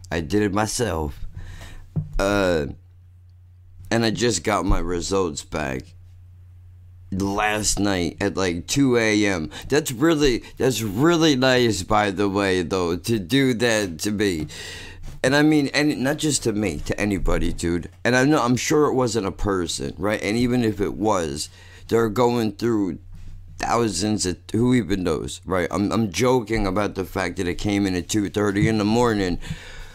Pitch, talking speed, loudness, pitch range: 100 Hz, 165 wpm, -22 LUFS, 90-115 Hz